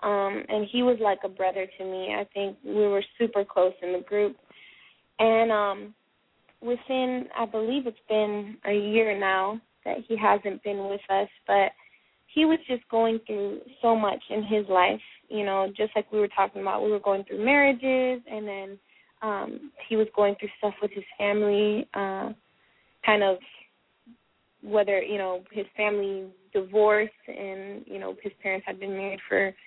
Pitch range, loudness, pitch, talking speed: 195-220 Hz, -27 LUFS, 205 Hz, 175 wpm